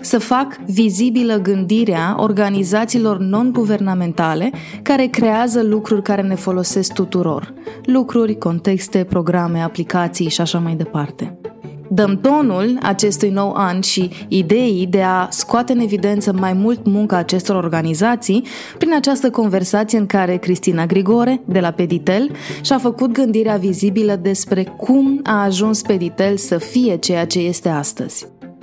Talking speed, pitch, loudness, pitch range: 130 wpm, 200 Hz, -16 LUFS, 185-225 Hz